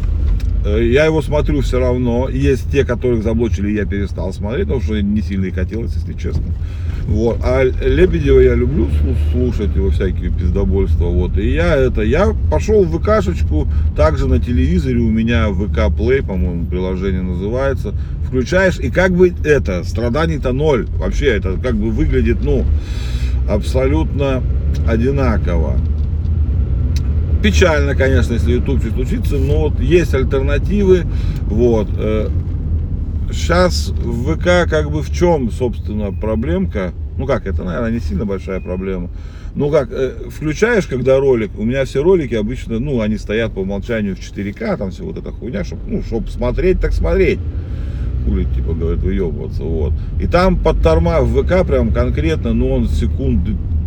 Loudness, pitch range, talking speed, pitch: -16 LUFS, 80-105 Hz, 150 wpm, 85 Hz